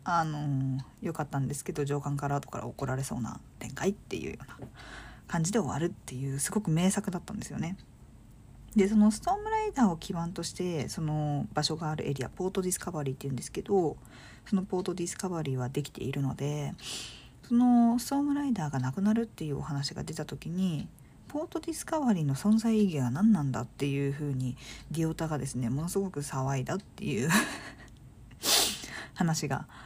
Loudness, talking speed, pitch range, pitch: -31 LUFS, 395 characters per minute, 140-195 Hz, 160 Hz